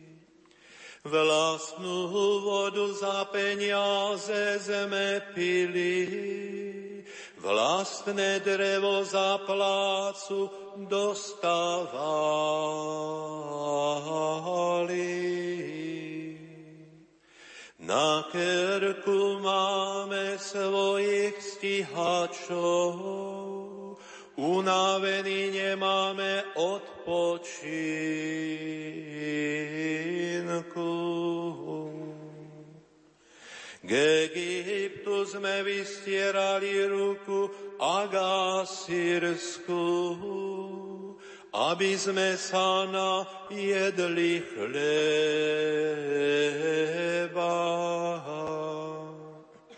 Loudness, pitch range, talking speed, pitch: -29 LUFS, 160-195 Hz, 35 wpm, 180 Hz